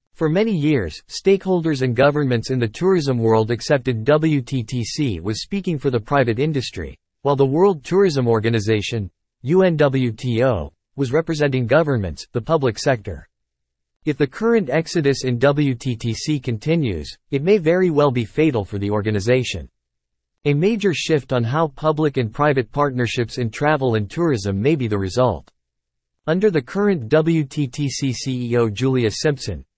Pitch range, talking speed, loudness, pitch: 110-155 Hz, 140 wpm, -19 LUFS, 130 Hz